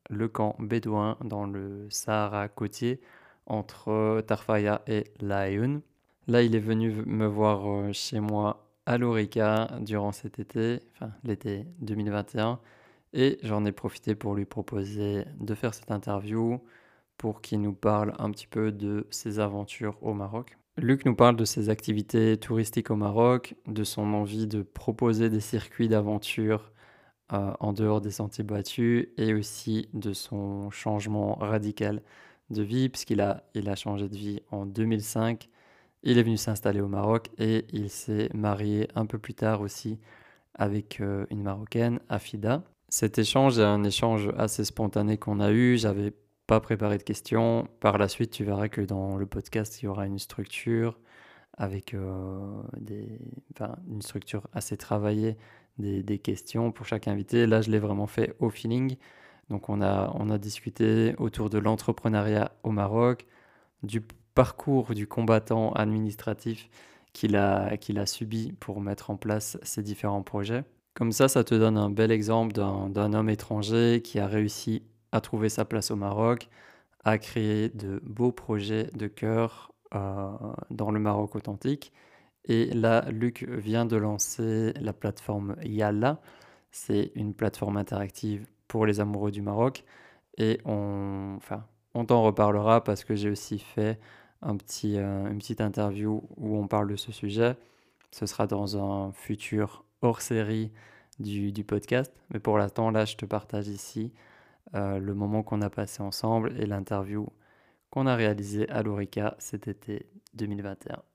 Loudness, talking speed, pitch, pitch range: -29 LUFS, 160 wpm, 110 Hz, 105-115 Hz